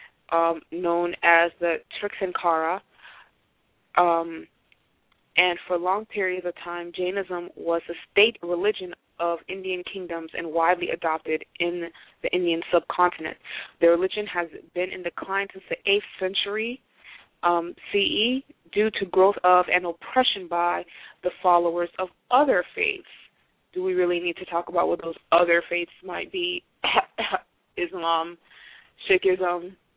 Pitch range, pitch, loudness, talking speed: 170-190 Hz, 175 Hz, -25 LUFS, 130 wpm